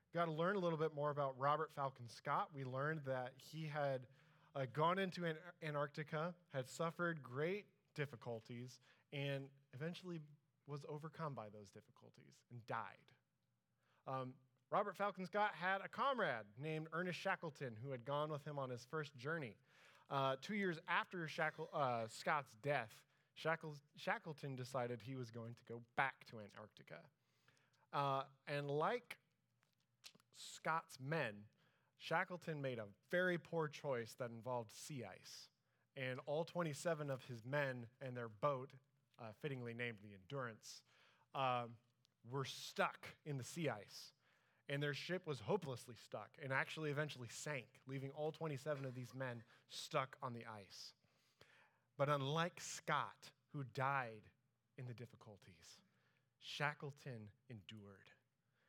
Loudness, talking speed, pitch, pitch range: -45 LUFS, 140 wpm, 140 Hz, 125-155 Hz